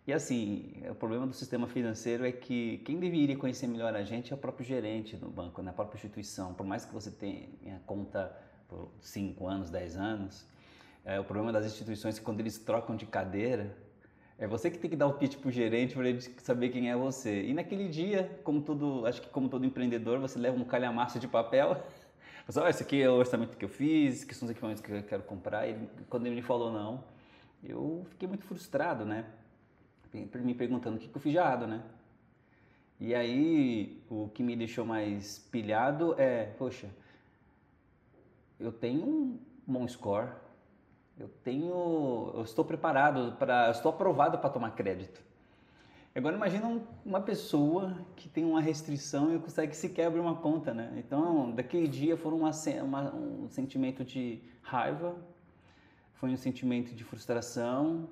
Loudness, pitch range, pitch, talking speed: -34 LUFS, 110-155 Hz, 125 Hz, 180 wpm